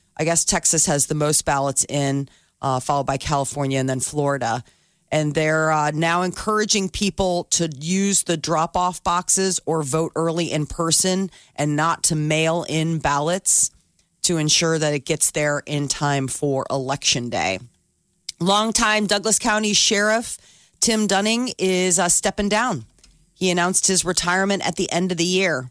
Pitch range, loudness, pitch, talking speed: 145-185 Hz, -20 LUFS, 165 Hz, 160 wpm